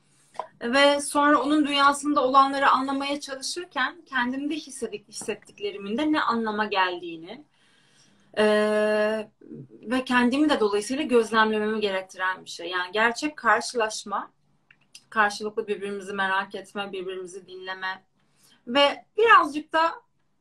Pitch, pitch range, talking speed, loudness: 220 Hz, 205-280 Hz, 105 wpm, -24 LUFS